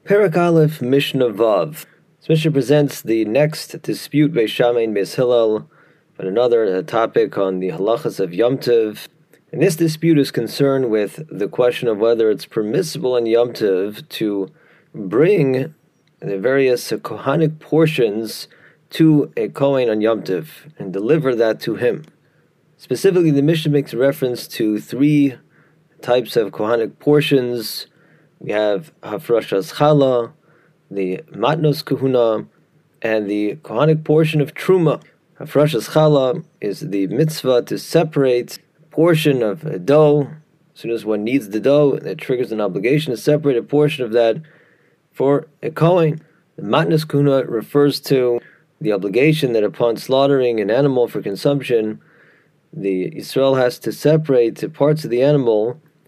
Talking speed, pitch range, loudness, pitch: 140 wpm, 120-155 Hz, -17 LUFS, 140 Hz